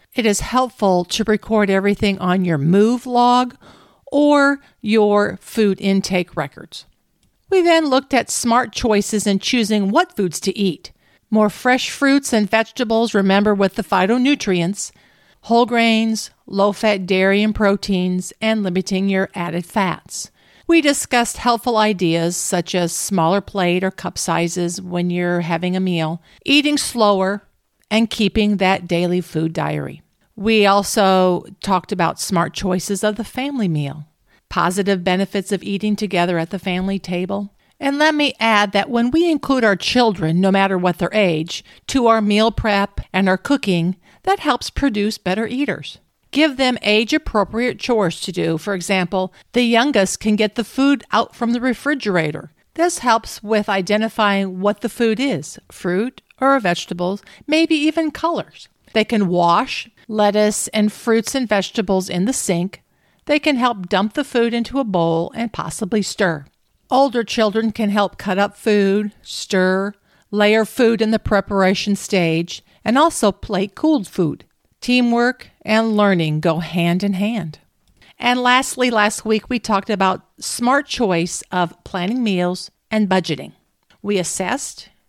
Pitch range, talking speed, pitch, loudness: 185-235 Hz, 150 wpm, 205 Hz, -18 LUFS